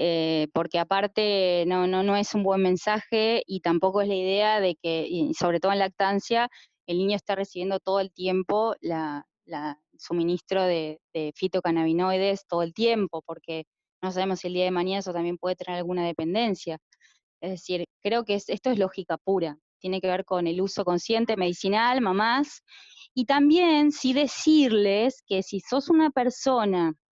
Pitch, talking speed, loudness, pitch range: 190 Hz, 175 wpm, -25 LUFS, 175-215 Hz